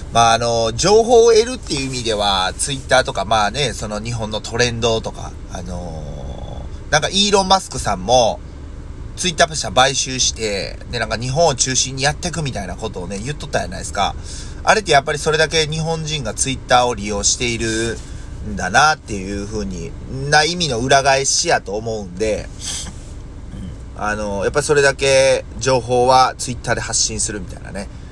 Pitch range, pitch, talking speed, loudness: 100-135 Hz, 115 Hz, 375 characters per minute, -17 LUFS